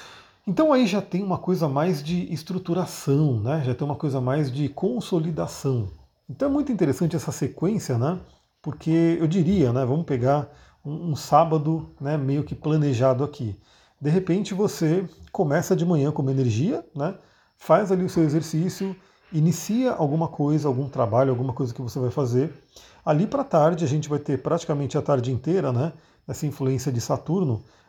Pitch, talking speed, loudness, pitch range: 150 Hz, 170 wpm, -24 LUFS, 135-175 Hz